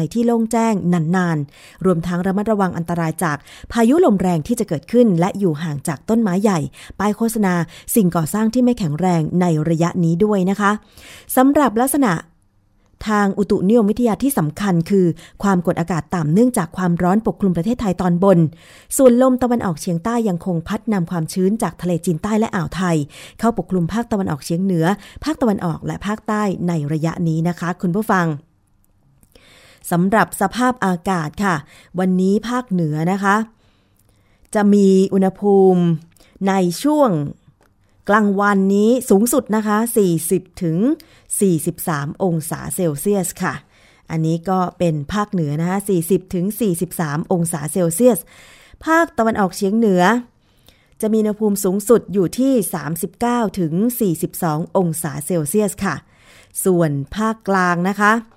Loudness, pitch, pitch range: -18 LUFS, 185 Hz, 170-215 Hz